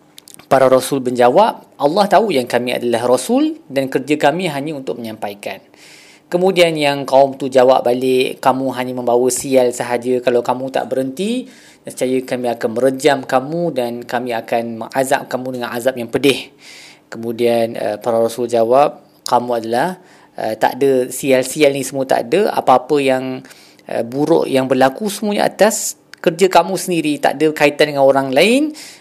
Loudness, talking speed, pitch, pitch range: -16 LUFS, 150 wpm, 130 Hz, 120-150 Hz